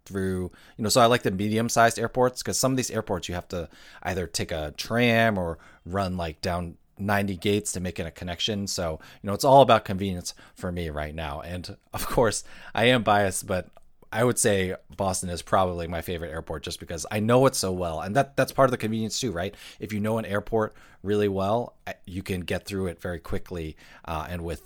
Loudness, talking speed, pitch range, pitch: -26 LUFS, 225 wpm, 90-110 Hz, 95 Hz